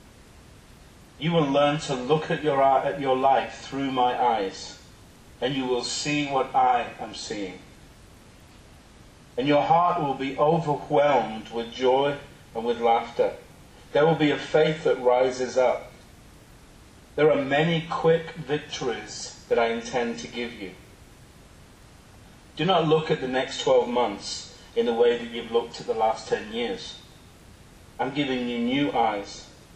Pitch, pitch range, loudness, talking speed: 140 Hz, 120-155 Hz, -25 LUFS, 150 wpm